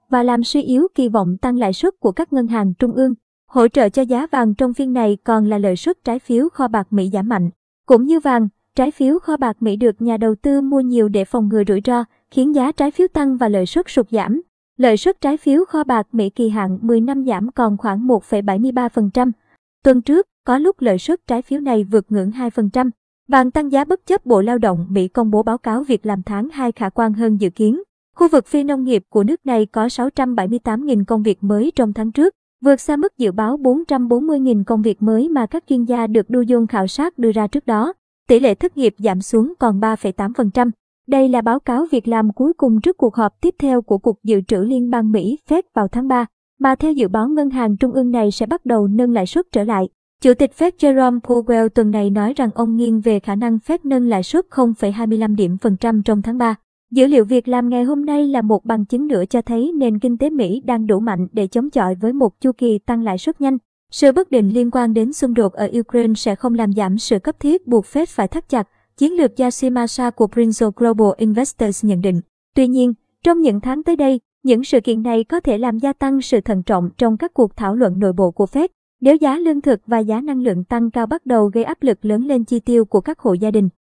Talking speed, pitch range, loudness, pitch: 245 wpm, 220-265 Hz, -17 LUFS, 240 Hz